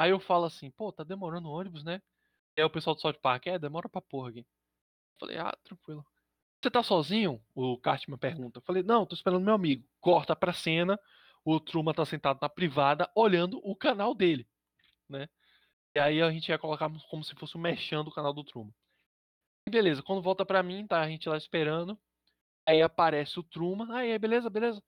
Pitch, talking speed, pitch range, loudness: 160 Hz, 200 wpm, 145-185 Hz, -30 LUFS